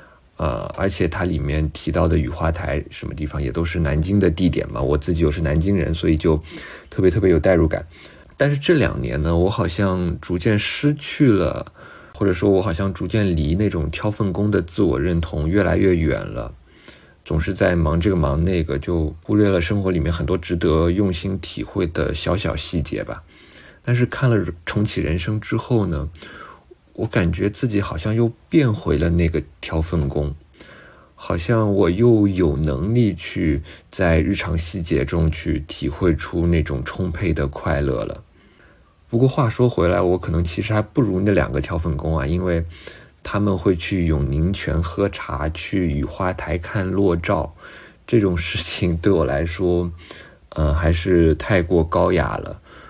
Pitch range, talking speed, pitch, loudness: 80-100 Hz, 250 characters per minute, 85 Hz, -20 LUFS